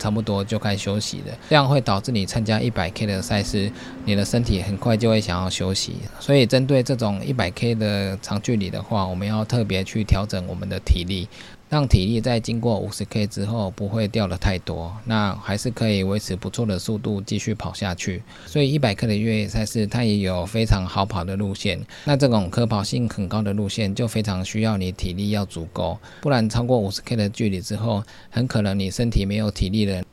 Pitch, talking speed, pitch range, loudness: 105 Hz, 315 characters per minute, 95-115 Hz, -23 LUFS